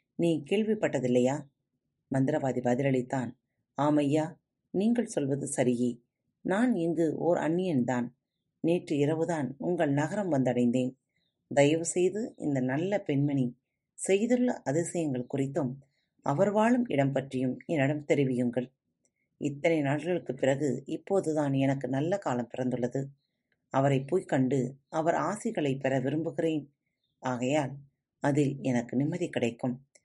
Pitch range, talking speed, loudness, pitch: 130-165 Hz, 100 wpm, -29 LUFS, 140 Hz